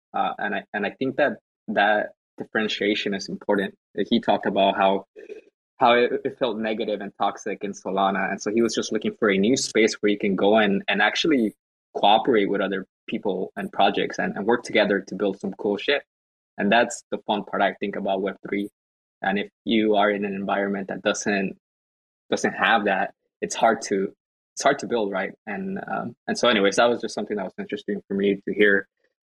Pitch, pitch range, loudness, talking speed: 100 Hz, 95-110 Hz, -23 LUFS, 205 wpm